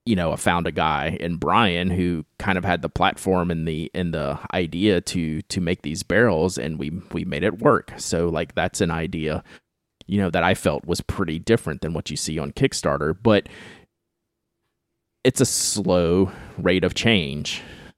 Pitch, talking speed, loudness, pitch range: 85 Hz, 185 wpm, -22 LUFS, 80-95 Hz